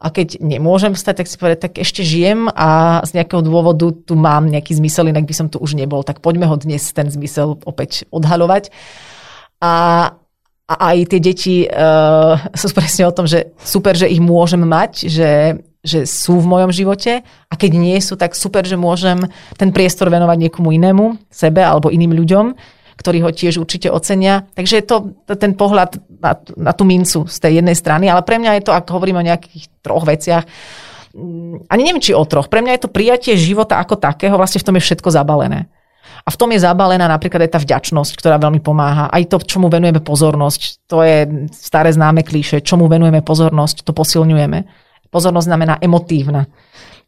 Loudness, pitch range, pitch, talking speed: -13 LUFS, 155-185 Hz, 170 Hz, 190 wpm